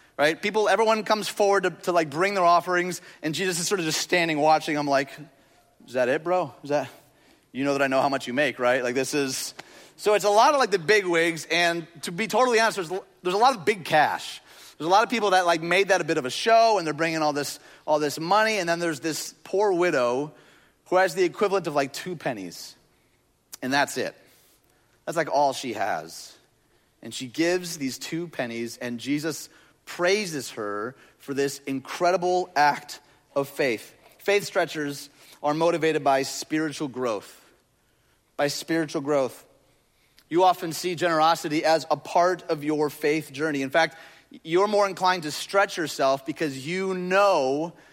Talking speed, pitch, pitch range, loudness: 190 wpm, 165 Hz, 145-185 Hz, -24 LUFS